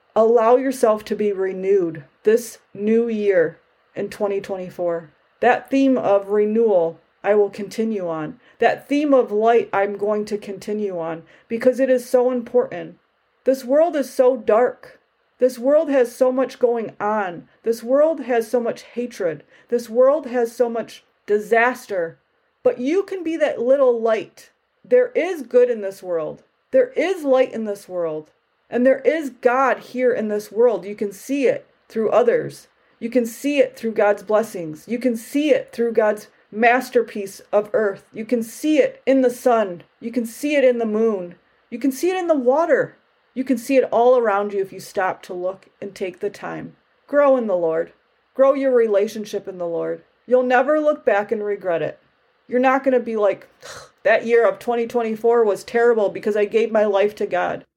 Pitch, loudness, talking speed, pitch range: 235 Hz, -20 LUFS, 185 wpm, 205-260 Hz